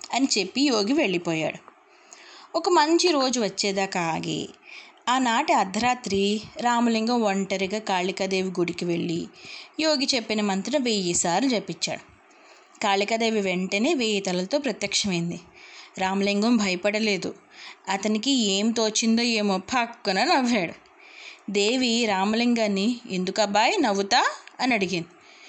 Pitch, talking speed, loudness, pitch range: 215 Hz, 95 wpm, -24 LUFS, 195-265 Hz